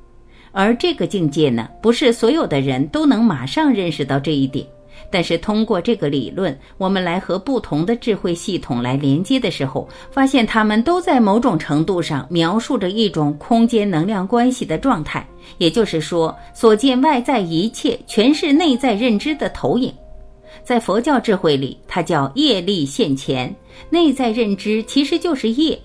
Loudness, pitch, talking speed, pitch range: -17 LUFS, 200 Hz, 260 characters per minute, 155-240 Hz